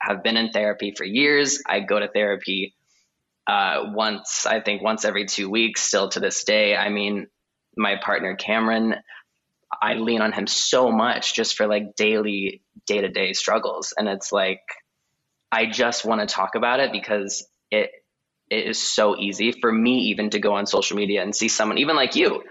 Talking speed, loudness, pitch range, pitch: 190 wpm, -22 LUFS, 100-110 Hz, 105 Hz